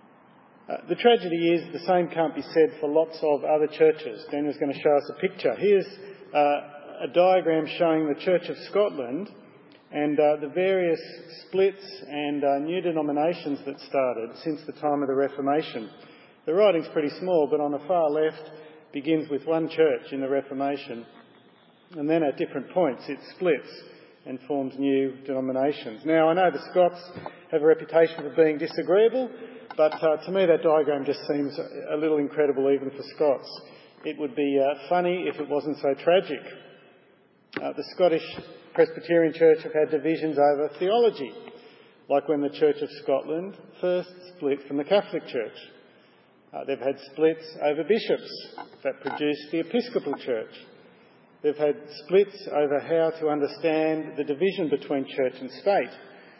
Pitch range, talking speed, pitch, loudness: 145-175 Hz, 165 wpm, 155 Hz, -25 LUFS